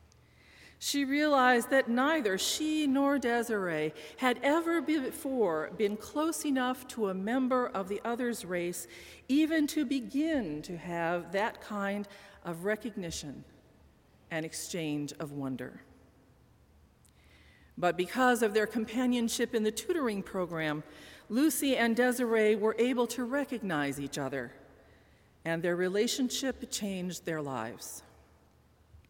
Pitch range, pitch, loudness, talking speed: 165-255 Hz, 215 Hz, -31 LUFS, 120 wpm